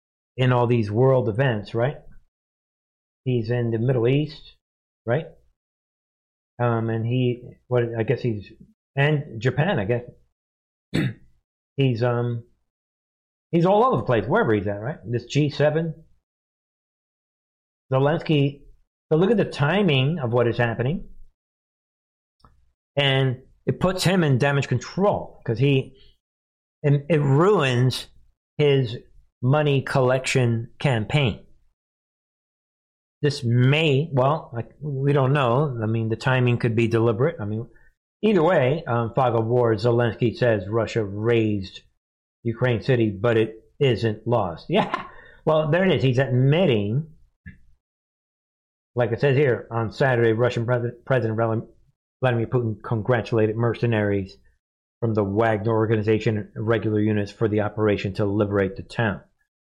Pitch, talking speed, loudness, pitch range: 120 Hz, 130 wpm, -22 LUFS, 110-135 Hz